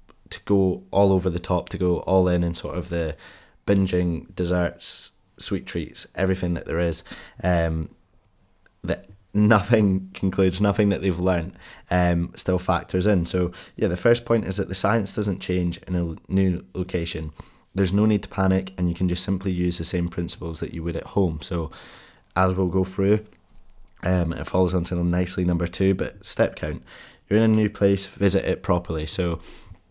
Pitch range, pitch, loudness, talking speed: 85-95 Hz, 90 Hz, -24 LUFS, 185 wpm